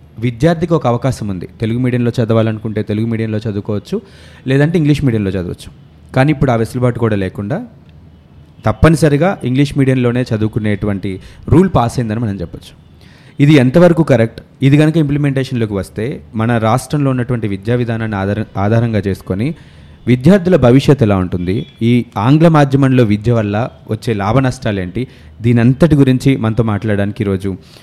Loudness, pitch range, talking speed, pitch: -14 LUFS, 105-135 Hz, 135 wpm, 120 Hz